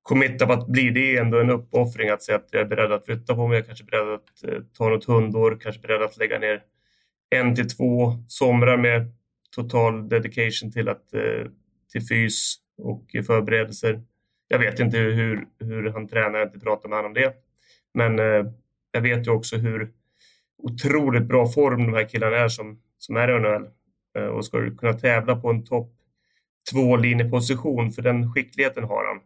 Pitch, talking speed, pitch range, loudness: 115 Hz, 195 wpm, 110-125 Hz, -22 LUFS